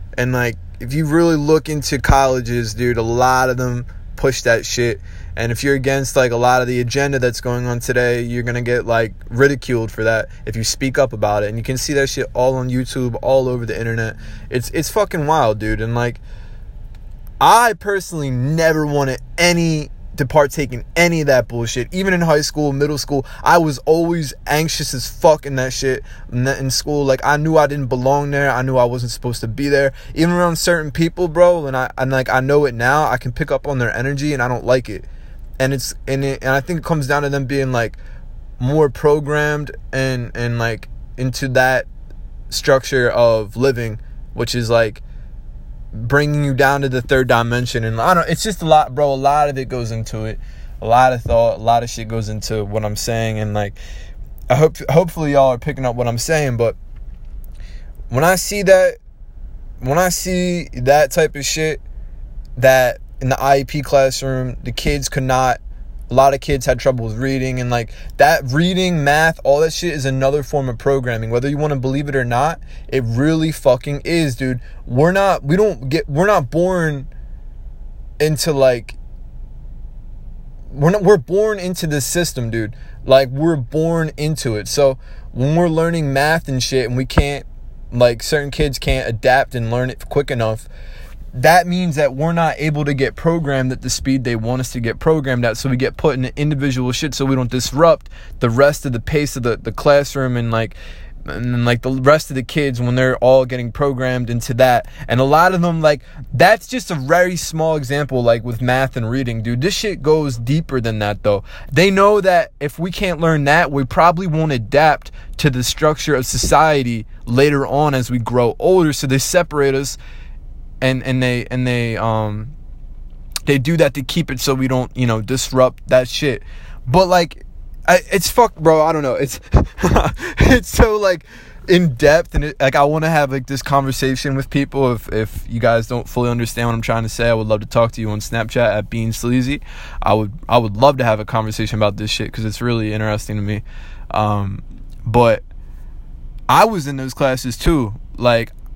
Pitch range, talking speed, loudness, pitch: 115-150 Hz, 205 wpm, -16 LUFS, 130 Hz